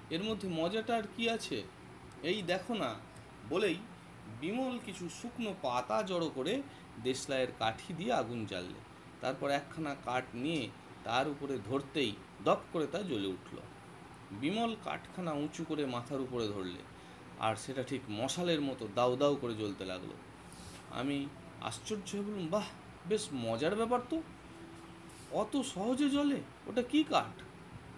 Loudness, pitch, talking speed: -36 LUFS, 145 Hz, 135 wpm